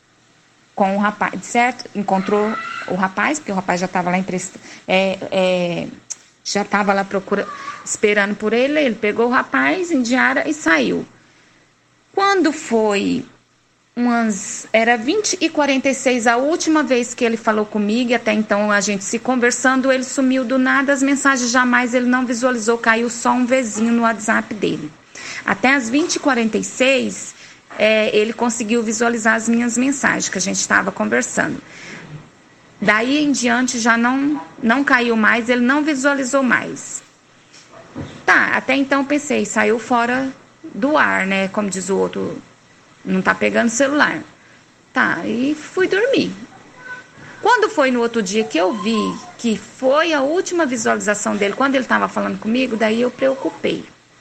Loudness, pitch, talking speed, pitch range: -17 LUFS, 240 Hz, 155 wpm, 215-275 Hz